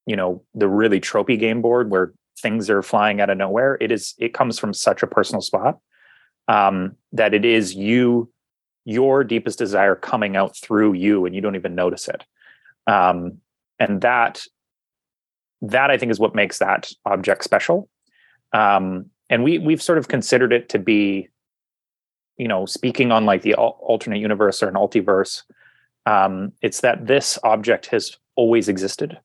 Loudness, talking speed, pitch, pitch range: -19 LUFS, 170 wpm, 105 Hz, 95-120 Hz